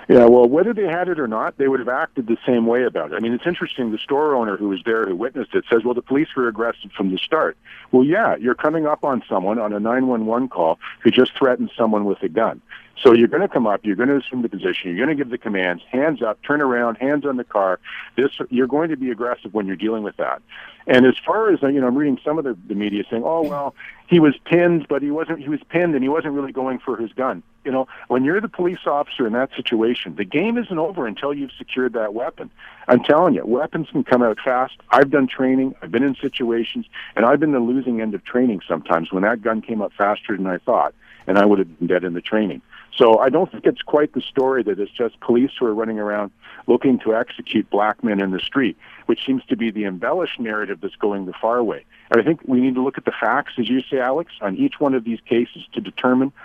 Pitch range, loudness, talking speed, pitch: 115-145 Hz, -19 LUFS, 265 wpm, 125 Hz